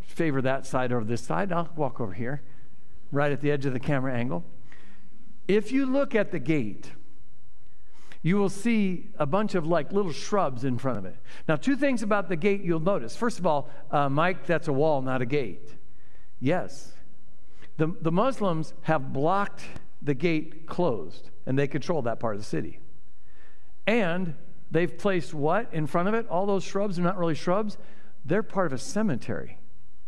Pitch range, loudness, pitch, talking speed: 140-195 Hz, -28 LUFS, 165 Hz, 185 wpm